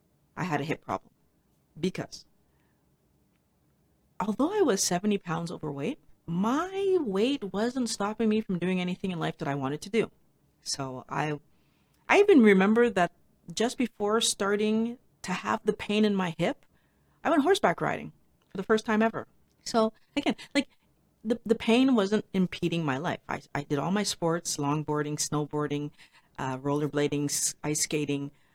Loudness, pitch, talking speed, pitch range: -28 LUFS, 185 Hz, 155 wpm, 150-225 Hz